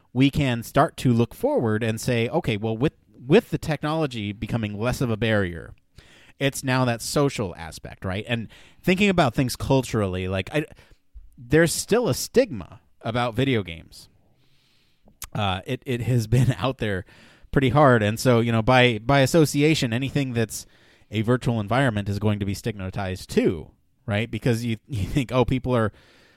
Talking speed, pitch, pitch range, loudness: 170 wpm, 120 Hz, 105-135 Hz, -23 LUFS